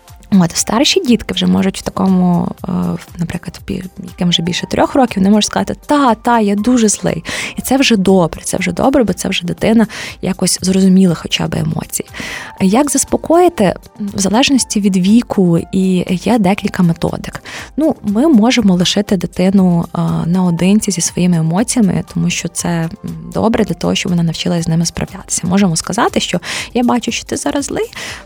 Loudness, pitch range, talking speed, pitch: -14 LUFS, 180-225 Hz, 165 wpm, 195 Hz